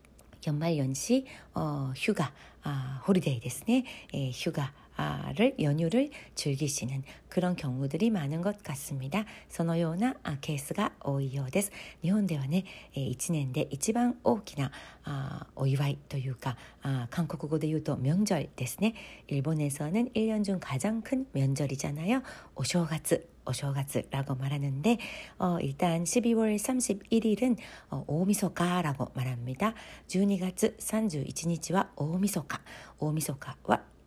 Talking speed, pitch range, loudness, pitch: 235 characters per minute, 140-205 Hz, -31 LUFS, 160 Hz